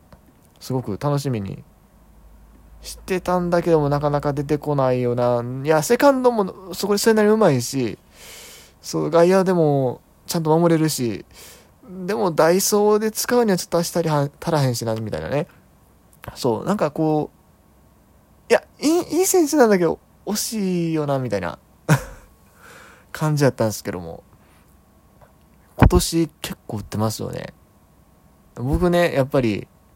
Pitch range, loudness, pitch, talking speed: 125-185 Hz, -20 LUFS, 155 Hz, 280 characters per minute